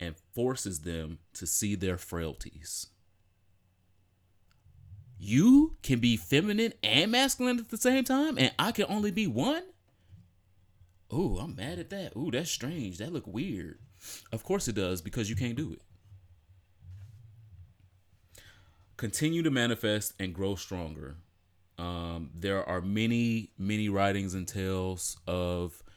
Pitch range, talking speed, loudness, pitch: 90-120 Hz, 135 wpm, -30 LUFS, 100 Hz